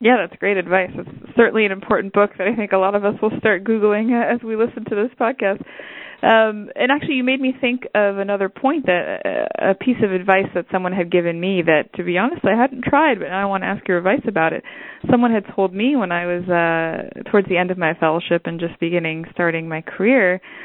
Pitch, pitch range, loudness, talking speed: 200 Hz, 180-240 Hz, -18 LUFS, 240 wpm